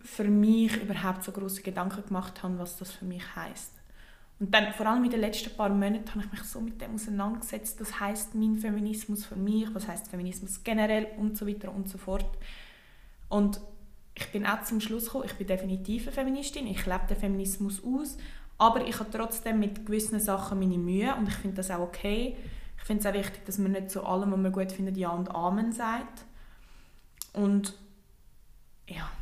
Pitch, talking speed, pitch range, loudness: 205 Hz, 200 wpm, 195-220 Hz, -31 LUFS